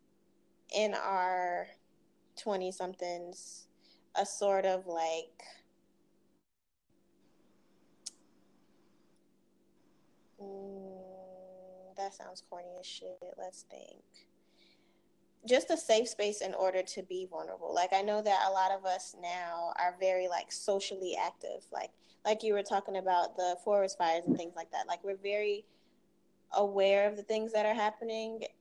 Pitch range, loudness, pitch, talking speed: 180-205 Hz, -34 LUFS, 190 Hz, 130 wpm